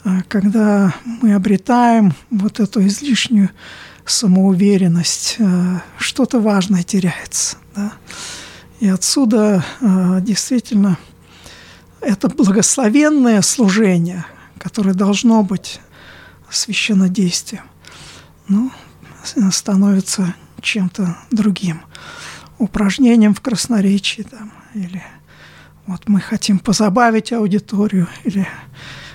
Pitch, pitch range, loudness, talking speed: 200 Hz, 185-220 Hz, -15 LUFS, 75 wpm